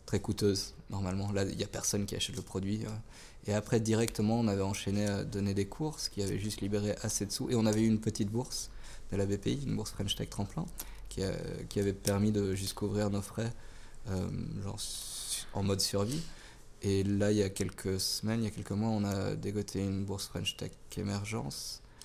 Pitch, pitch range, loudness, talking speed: 105 Hz, 100-110 Hz, -34 LUFS, 210 wpm